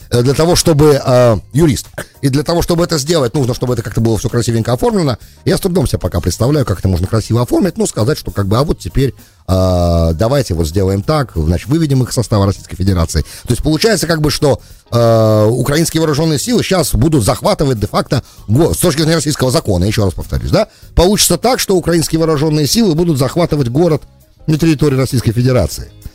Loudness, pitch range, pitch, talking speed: -13 LUFS, 105-160 Hz, 130 Hz, 190 wpm